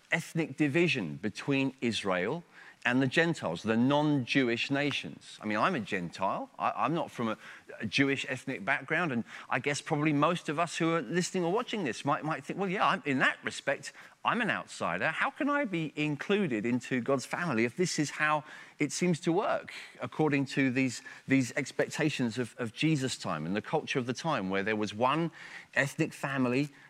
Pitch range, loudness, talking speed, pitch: 130-160 Hz, -31 LUFS, 195 wpm, 145 Hz